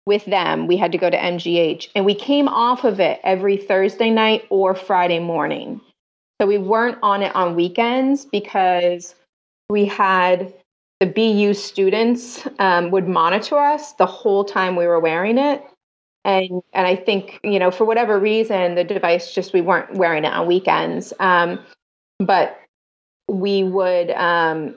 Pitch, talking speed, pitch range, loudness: 195 Hz, 160 wpm, 180-210 Hz, -18 LUFS